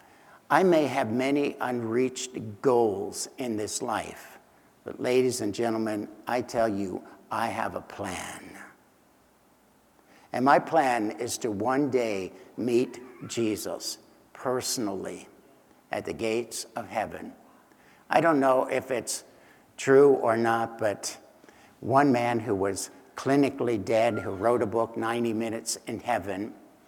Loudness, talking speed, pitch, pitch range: -27 LUFS, 130 wpm, 115 Hz, 110-130 Hz